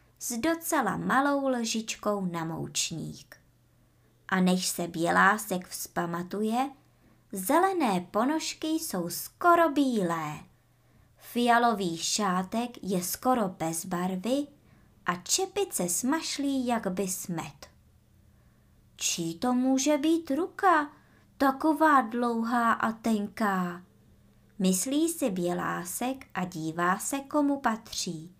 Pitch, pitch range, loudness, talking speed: 215 Hz, 175-275 Hz, -28 LUFS, 95 wpm